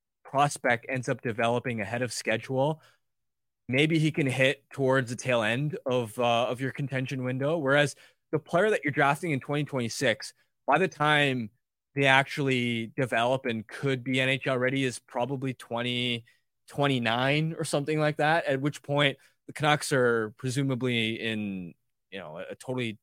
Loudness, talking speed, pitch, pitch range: -27 LUFS, 160 wpm, 130 Hz, 120-145 Hz